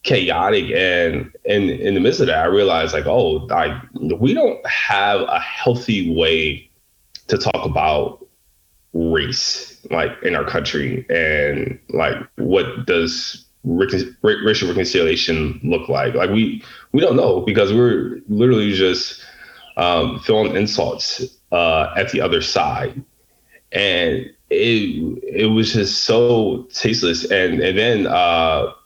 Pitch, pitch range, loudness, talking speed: 105 Hz, 85-125 Hz, -18 LUFS, 135 wpm